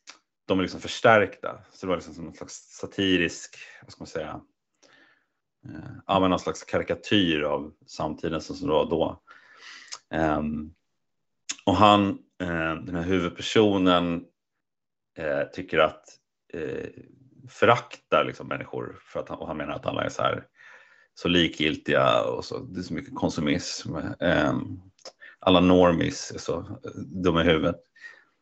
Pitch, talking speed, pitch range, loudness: 95 Hz, 130 wpm, 85-135 Hz, -25 LUFS